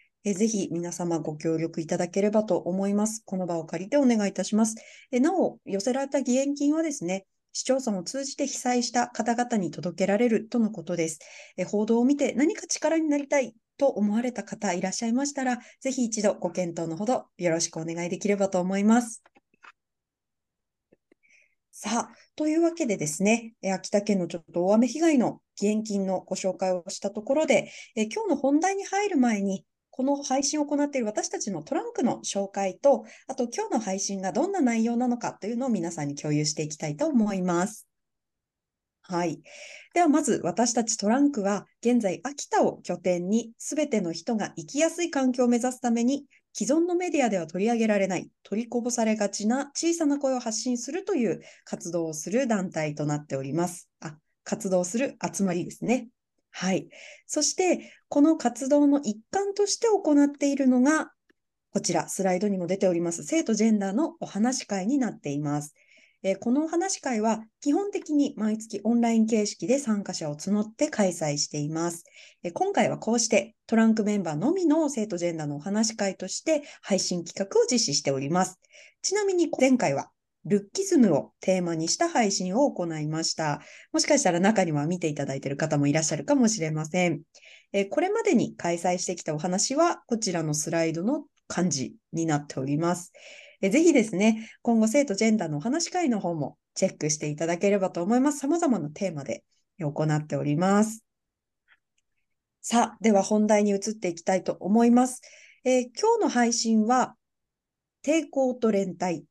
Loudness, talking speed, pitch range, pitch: -26 LUFS, 360 characters per minute, 180-275 Hz, 220 Hz